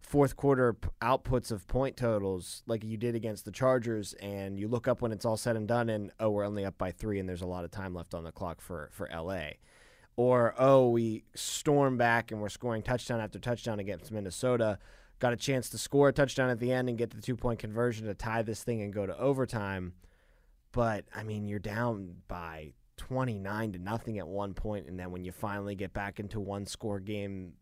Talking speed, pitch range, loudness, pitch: 225 wpm, 95-120 Hz, -32 LUFS, 110 Hz